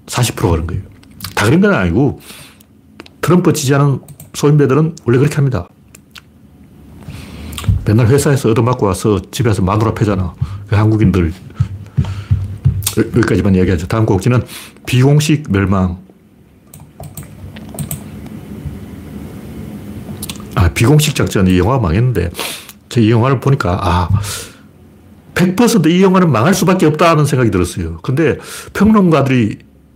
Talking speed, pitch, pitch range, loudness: 255 characters per minute, 110 Hz, 95-140 Hz, -13 LUFS